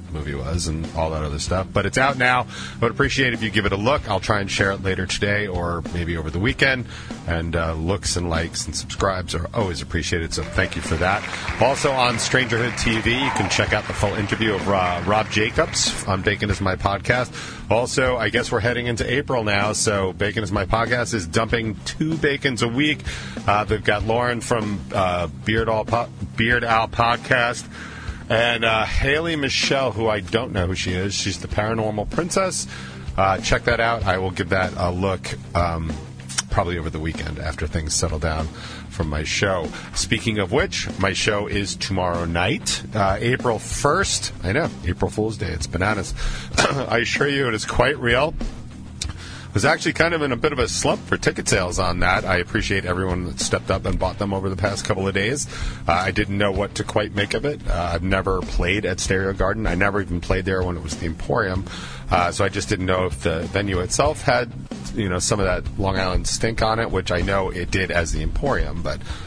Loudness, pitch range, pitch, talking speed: -22 LUFS, 90-115 Hz, 100 Hz, 215 wpm